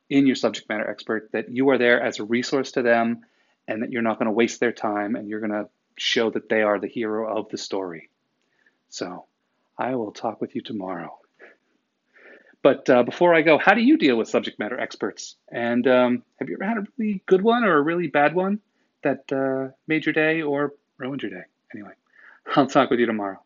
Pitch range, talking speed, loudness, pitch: 115-165 Hz, 220 wpm, -22 LUFS, 135 Hz